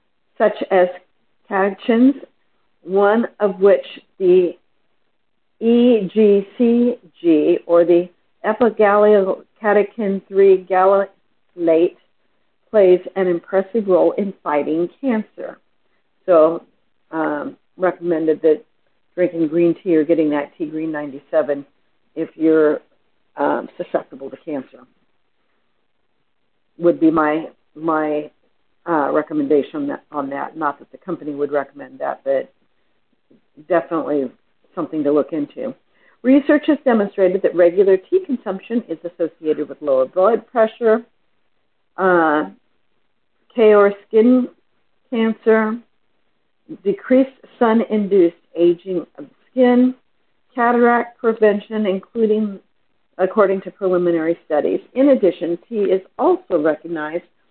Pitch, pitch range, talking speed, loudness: 190 Hz, 165-230 Hz, 100 wpm, -18 LUFS